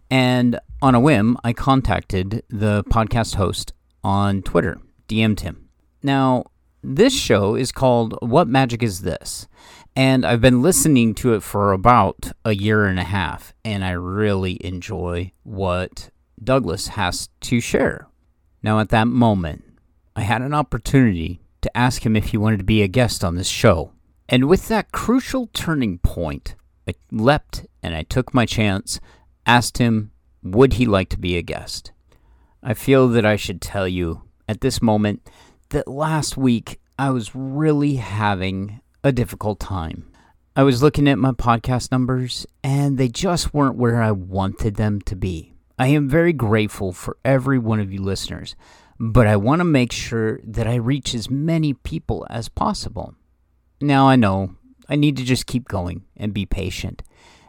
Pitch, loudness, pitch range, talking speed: 110 Hz, -19 LUFS, 95-130 Hz, 165 wpm